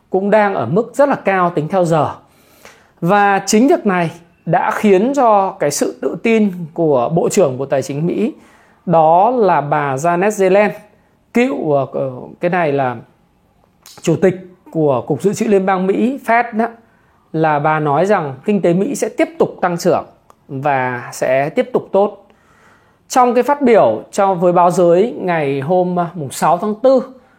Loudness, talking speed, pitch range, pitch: -15 LUFS, 170 wpm, 160-215 Hz, 185 Hz